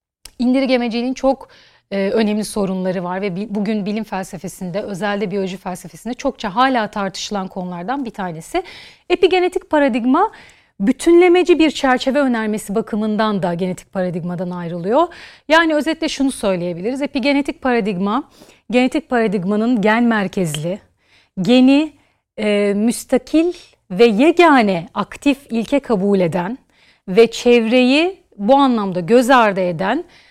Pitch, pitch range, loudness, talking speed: 225 Hz, 195-270 Hz, -17 LUFS, 115 wpm